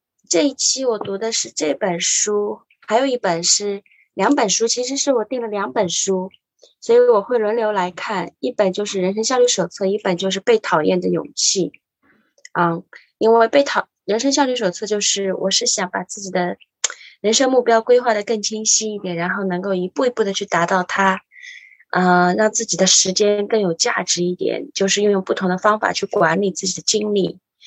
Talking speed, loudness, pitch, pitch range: 280 characters per minute, -18 LUFS, 205 Hz, 185-230 Hz